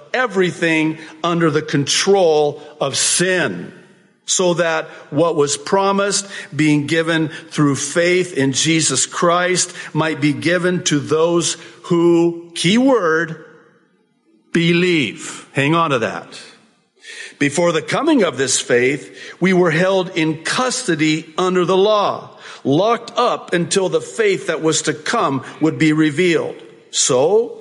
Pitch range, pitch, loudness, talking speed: 155-185 Hz, 170 Hz, -16 LUFS, 125 wpm